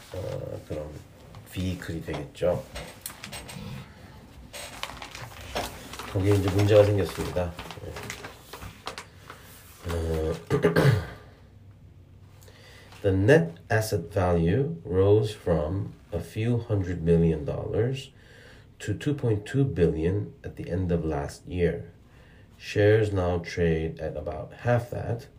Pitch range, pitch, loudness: 85-110 Hz, 100 Hz, -27 LUFS